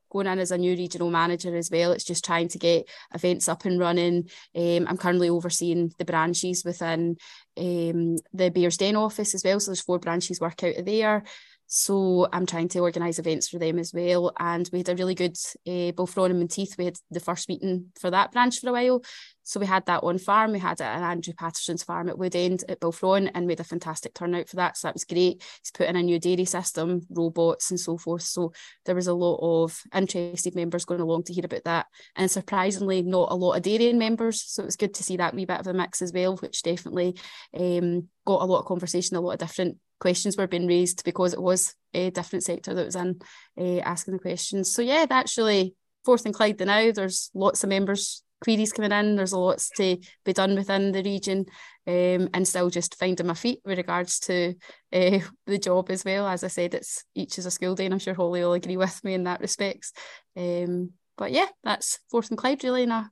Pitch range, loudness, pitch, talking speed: 175-195 Hz, -26 LUFS, 180 Hz, 235 wpm